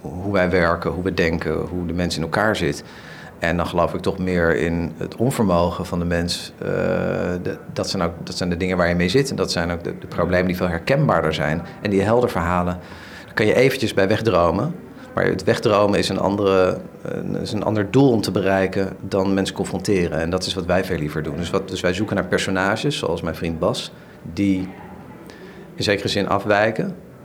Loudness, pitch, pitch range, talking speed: -21 LUFS, 95 Hz, 85-100 Hz, 210 wpm